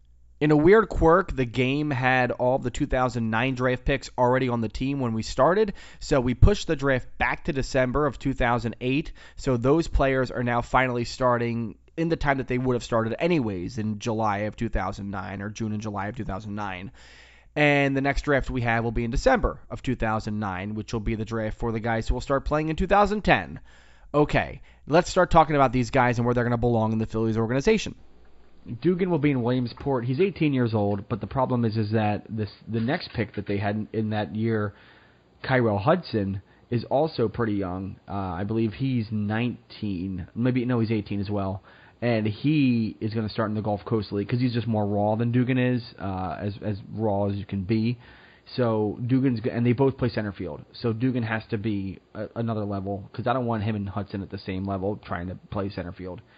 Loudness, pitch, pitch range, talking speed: -25 LUFS, 115 Hz, 105-130 Hz, 215 wpm